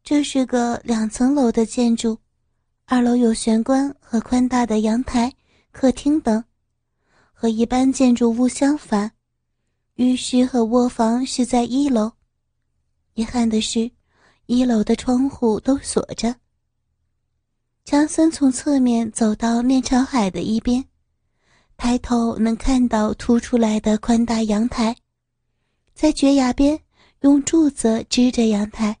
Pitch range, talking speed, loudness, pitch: 225-260 Hz, 185 characters per minute, -19 LUFS, 240 Hz